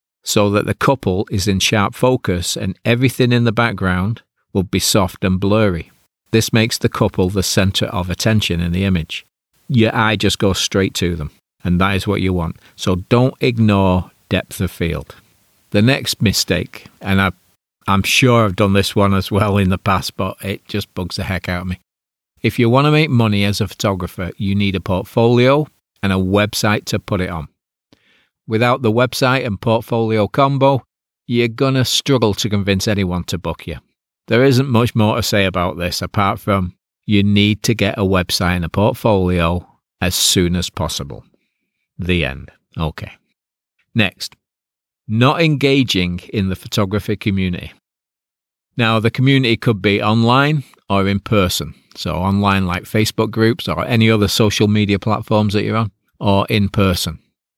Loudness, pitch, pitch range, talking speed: -16 LUFS, 100 Hz, 95-115 Hz, 175 wpm